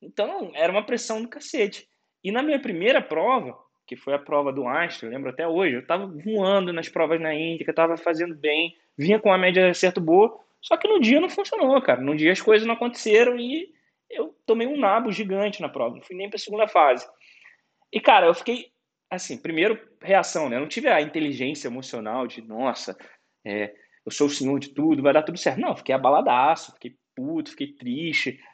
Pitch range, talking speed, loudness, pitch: 160-255 Hz, 210 wpm, -23 LUFS, 195 Hz